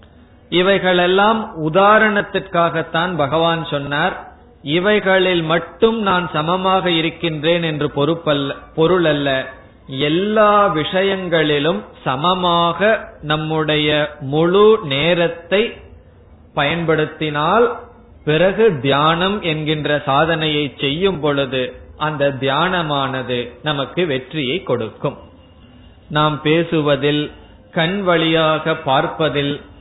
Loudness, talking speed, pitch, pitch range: -17 LUFS, 70 wpm, 160 Hz, 145-180 Hz